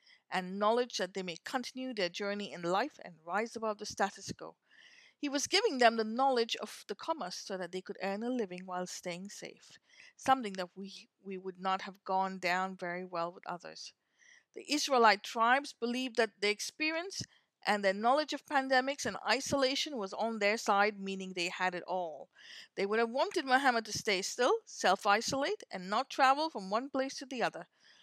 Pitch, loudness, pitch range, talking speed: 215 Hz, -33 LUFS, 190-265 Hz, 195 wpm